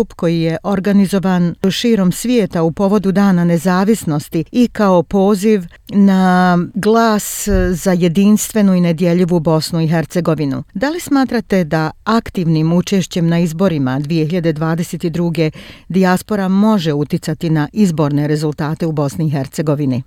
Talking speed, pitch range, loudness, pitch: 120 wpm, 165-200 Hz, -15 LUFS, 180 Hz